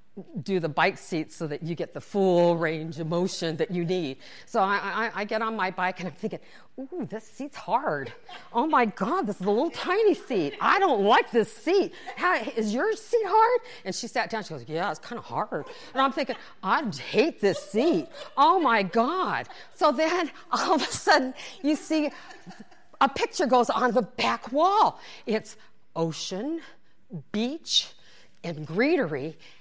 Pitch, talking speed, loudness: 225 Hz, 185 wpm, -26 LUFS